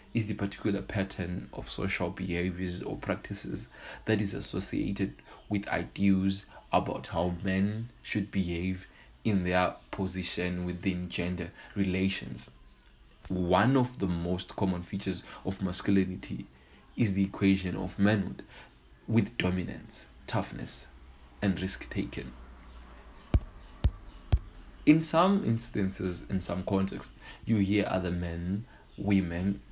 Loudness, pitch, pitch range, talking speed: -31 LUFS, 95 Hz, 85-100 Hz, 110 wpm